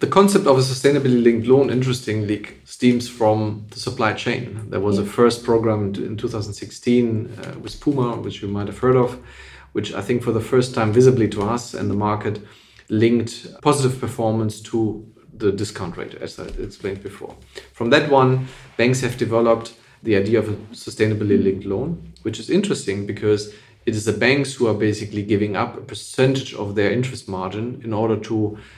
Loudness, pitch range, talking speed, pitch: -20 LUFS, 105-125 Hz, 180 wpm, 115 Hz